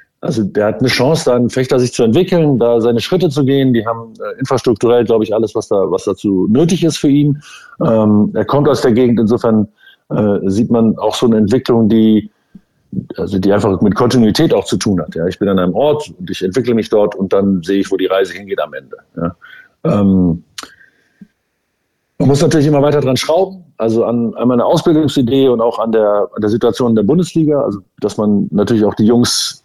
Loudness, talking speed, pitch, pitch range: -13 LUFS, 215 wpm, 120 Hz, 105-140 Hz